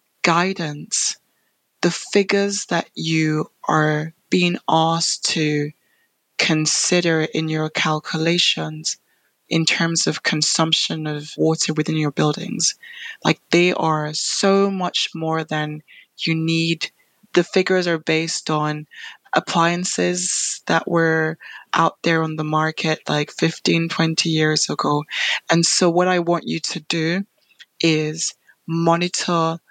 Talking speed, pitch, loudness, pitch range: 120 wpm, 165 Hz, -20 LUFS, 155-175 Hz